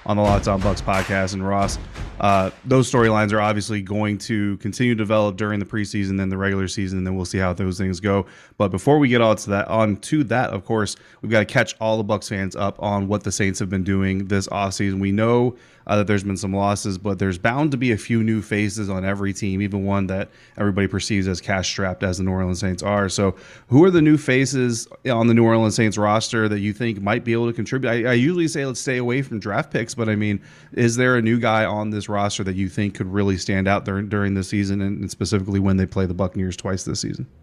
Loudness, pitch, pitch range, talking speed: -21 LUFS, 105 Hz, 95-110 Hz, 255 wpm